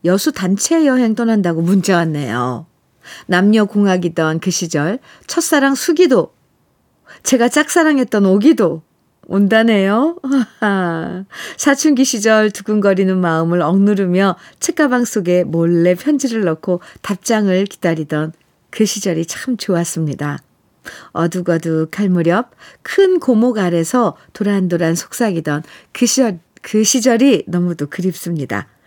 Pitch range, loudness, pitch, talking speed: 170-240 Hz, -15 LUFS, 195 Hz, 260 characters per minute